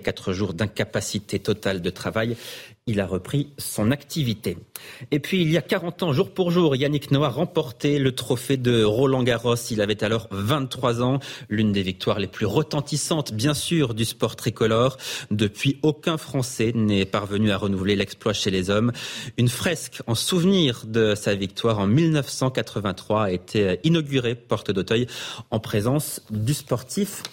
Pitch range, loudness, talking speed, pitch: 110-145 Hz, -23 LUFS, 160 wpm, 120 Hz